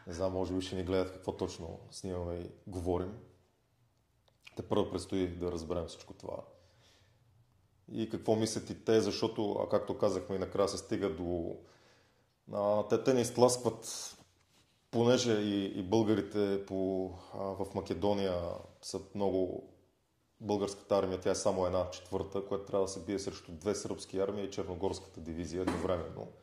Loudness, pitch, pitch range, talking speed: -35 LUFS, 100 Hz, 95-110 Hz, 150 wpm